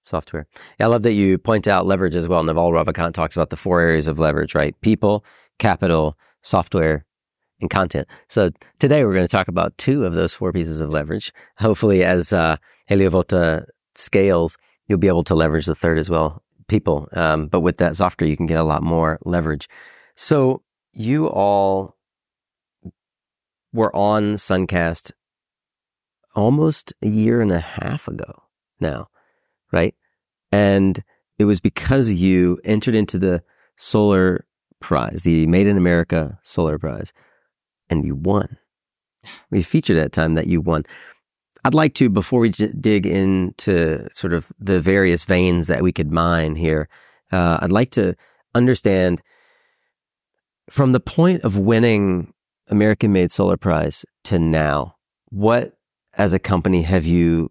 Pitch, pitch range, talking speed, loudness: 90 Hz, 85-105 Hz, 155 wpm, -19 LUFS